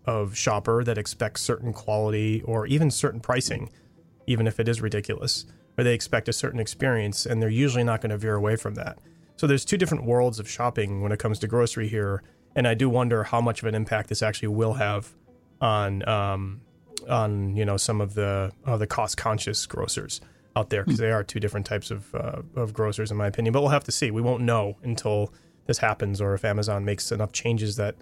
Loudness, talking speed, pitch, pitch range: -26 LUFS, 220 wpm, 110 Hz, 105-120 Hz